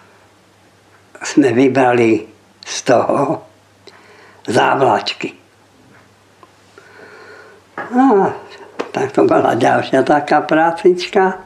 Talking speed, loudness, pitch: 70 wpm, -14 LUFS, 180 Hz